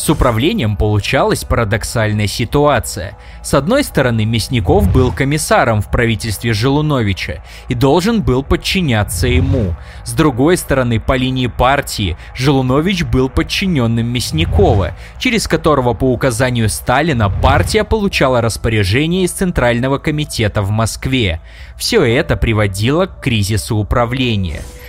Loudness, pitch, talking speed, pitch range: -14 LUFS, 120 Hz, 115 wpm, 105-140 Hz